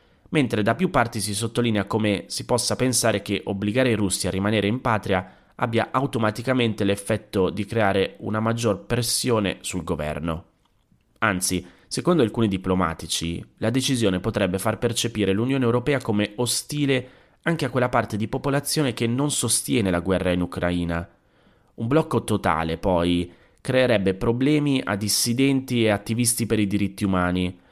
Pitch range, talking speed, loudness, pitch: 95-120 Hz, 145 wpm, -23 LUFS, 110 Hz